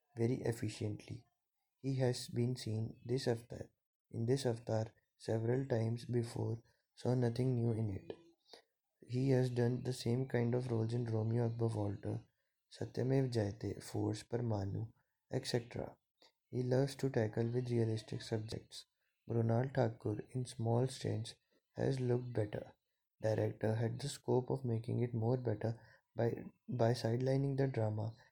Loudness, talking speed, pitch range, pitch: -38 LUFS, 140 wpm, 110-125 Hz, 120 Hz